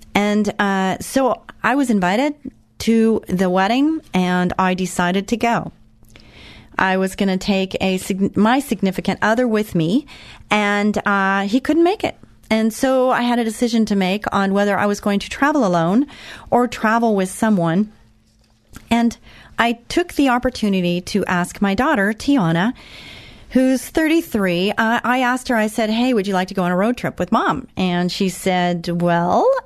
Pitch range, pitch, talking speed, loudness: 185-240 Hz, 205 Hz, 170 wpm, -18 LUFS